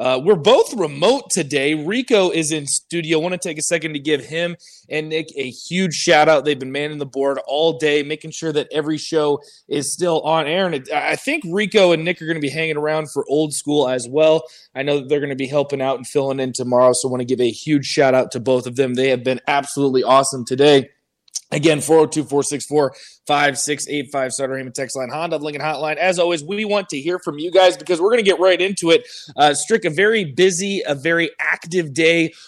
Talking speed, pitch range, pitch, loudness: 230 wpm, 140-170 Hz, 155 Hz, -18 LUFS